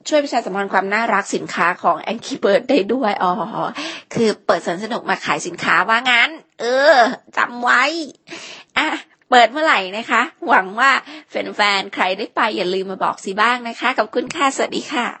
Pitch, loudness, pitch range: 235 Hz, -17 LUFS, 210-275 Hz